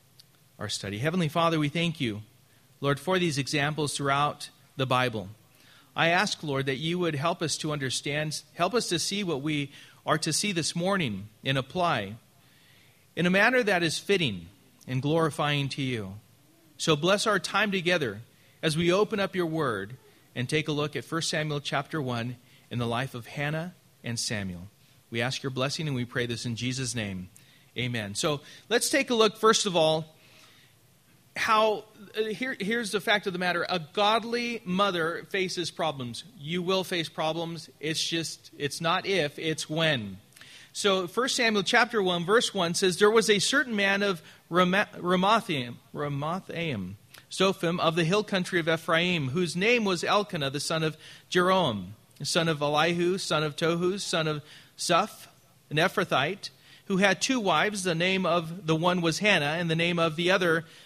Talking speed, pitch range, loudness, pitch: 175 wpm, 135-185 Hz, -27 LUFS, 160 Hz